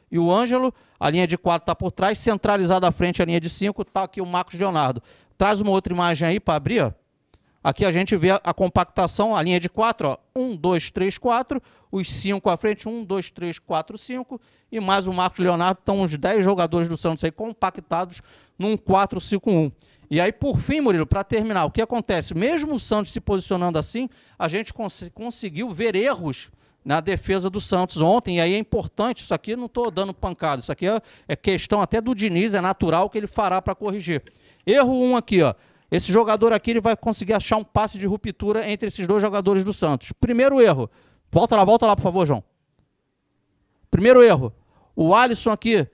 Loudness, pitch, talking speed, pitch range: -21 LUFS, 195 Hz, 205 wpm, 175-220 Hz